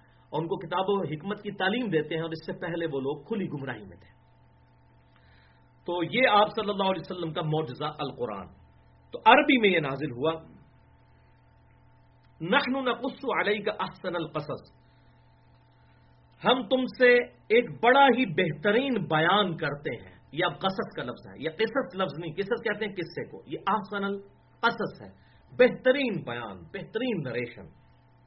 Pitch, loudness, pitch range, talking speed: 180 Hz, -27 LUFS, 150-220 Hz, 155 wpm